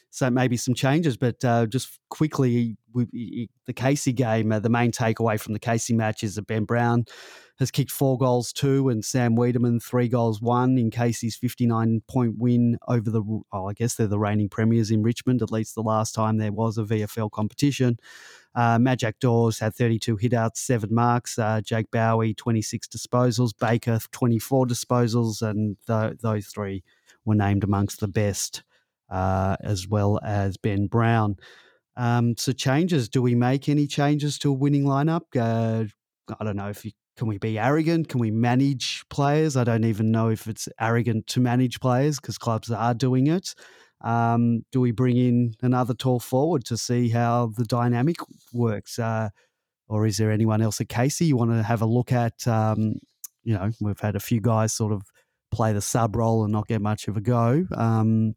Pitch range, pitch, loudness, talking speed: 110-125 Hz, 115 Hz, -24 LUFS, 190 wpm